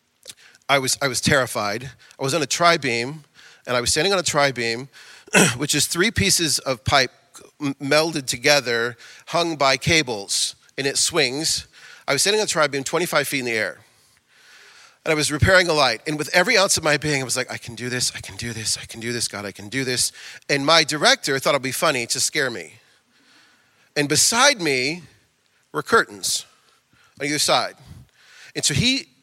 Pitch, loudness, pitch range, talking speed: 140 Hz, -20 LUFS, 125-160 Hz, 200 wpm